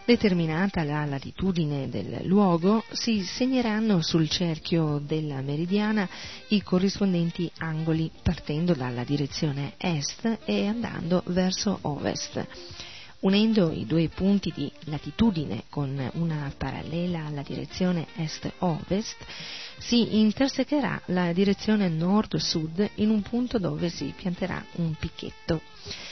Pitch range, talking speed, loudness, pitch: 155-205 Hz, 110 wpm, -27 LUFS, 175 Hz